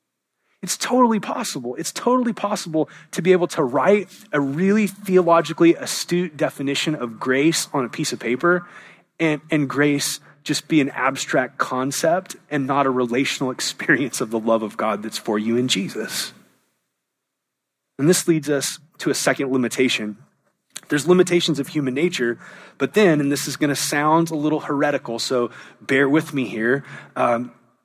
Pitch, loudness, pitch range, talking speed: 150 Hz, -20 LUFS, 130-175 Hz, 165 wpm